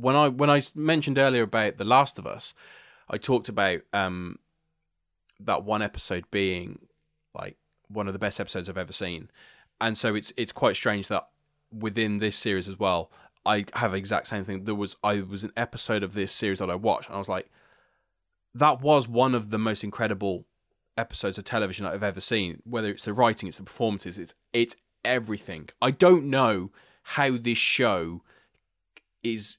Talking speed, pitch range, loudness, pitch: 185 wpm, 95-120 Hz, -26 LUFS, 105 Hz